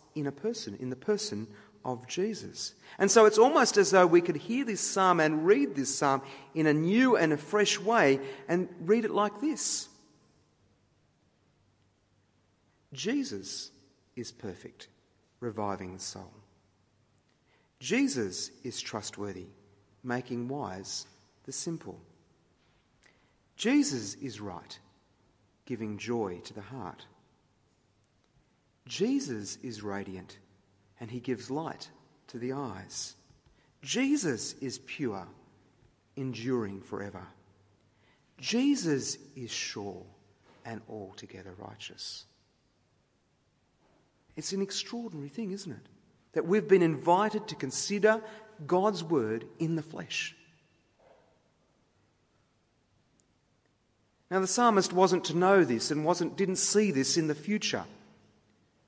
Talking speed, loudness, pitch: 110 wpm, -30 LUFS, 130 Hz